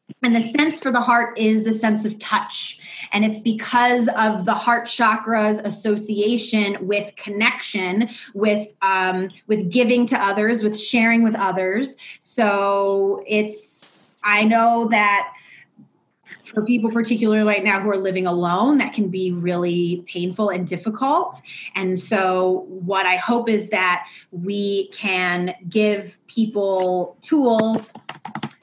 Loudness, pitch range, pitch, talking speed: -20 LUFS, 195-230 Hz, 210 Hz, 135 wpm